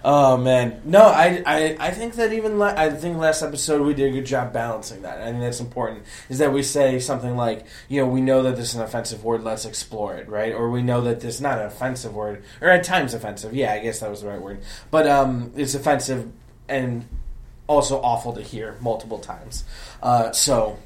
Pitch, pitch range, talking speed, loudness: 120 Hz, 110-140 Hz, 235 wpm, -21 LUFS